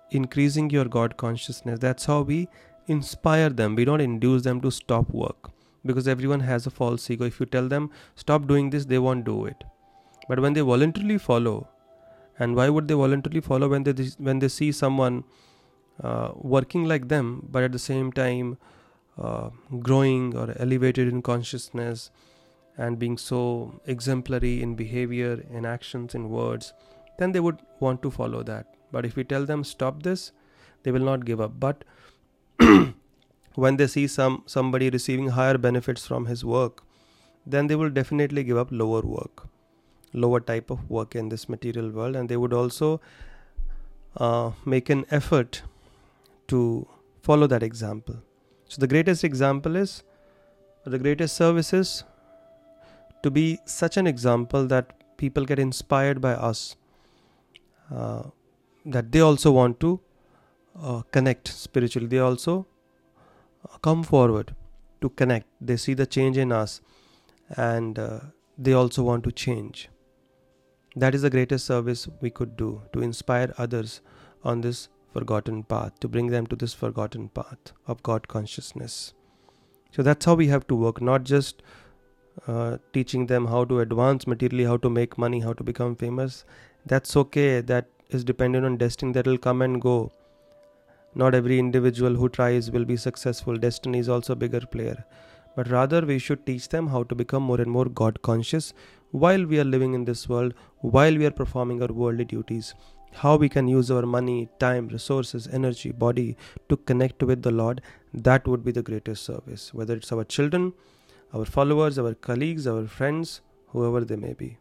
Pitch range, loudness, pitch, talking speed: 120-140 Hz, -25 LUFS, 125 Hz, 170 wpm